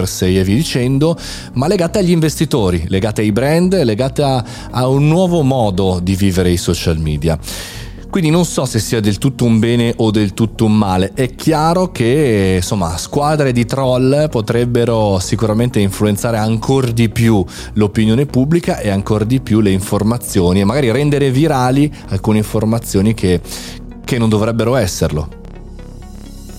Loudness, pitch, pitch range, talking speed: -14 LUFS, 110 Hz, 95-135 Hz, 155 wpm